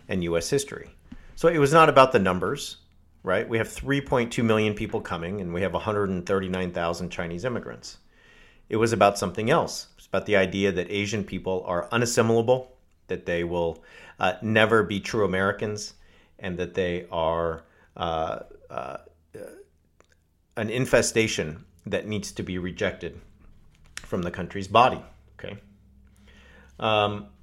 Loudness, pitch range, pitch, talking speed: -25 LUFS, 85-110 Hz, 95 Hz, 140 wpm